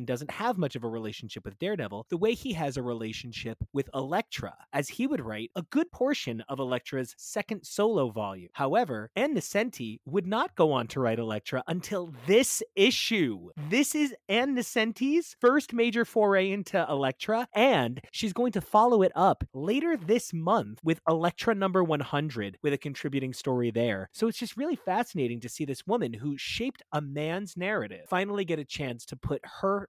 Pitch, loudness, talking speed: 175 Hz, -29 LUFS, 180 wpm